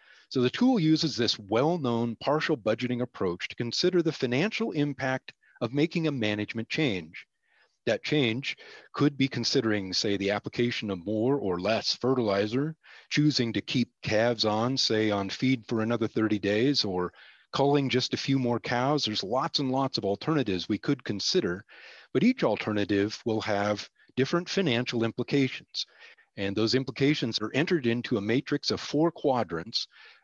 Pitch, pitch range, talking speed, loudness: 125 Hz, 110-145 Hz, 160 wpm, -28 LUFS